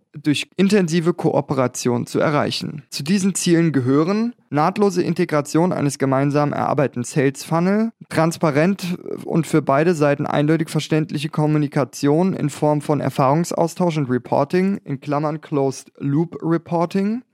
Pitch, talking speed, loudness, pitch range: 155 Hz, 120 wpm, -19 LUFS, 145-175 Hz